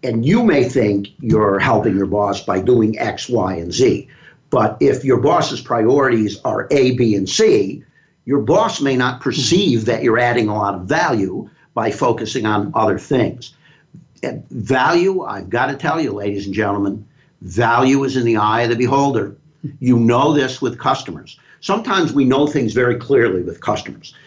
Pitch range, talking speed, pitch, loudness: 105-140 Hz, 175 wpm, 120 Hz, -16 LUFS